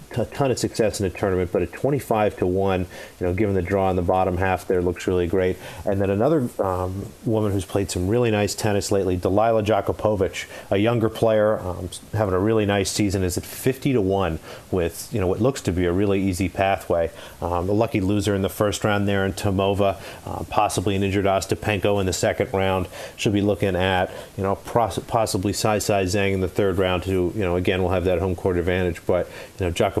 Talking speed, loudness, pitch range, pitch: 230 wpm, -22 LUFS, 95-105 Hz, 100 Hz